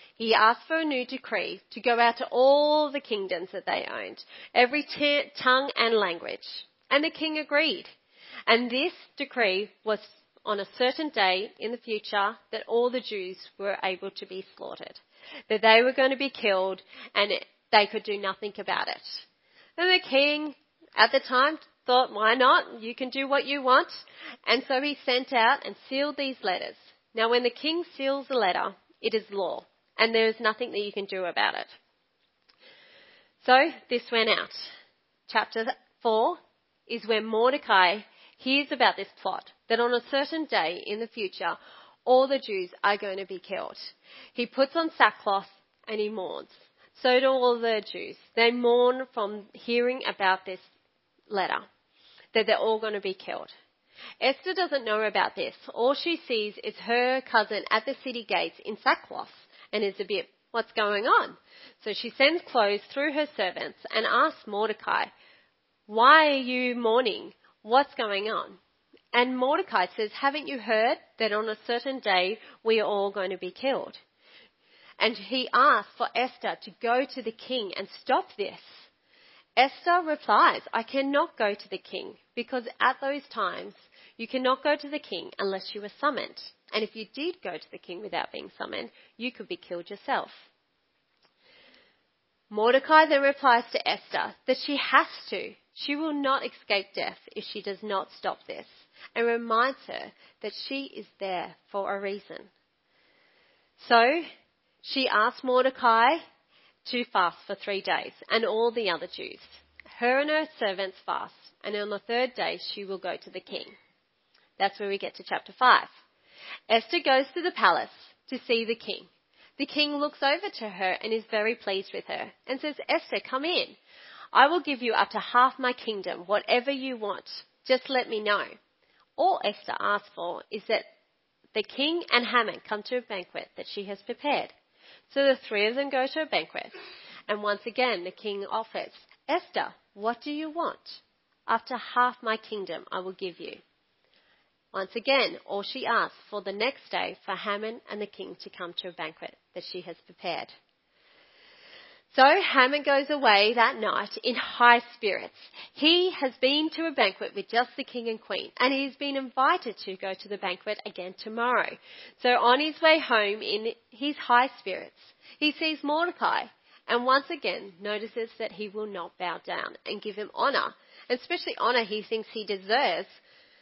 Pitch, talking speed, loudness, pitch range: 240 Hz, 175 wpm, -27 LUFS, 210-280 Hz